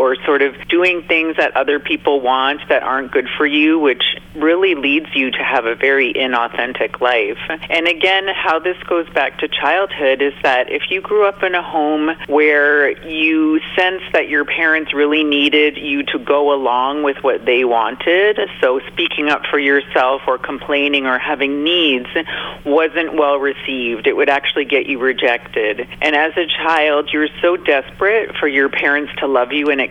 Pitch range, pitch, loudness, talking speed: 140-170 Hz, 150 Hz, -15 LUFS, 185 wpm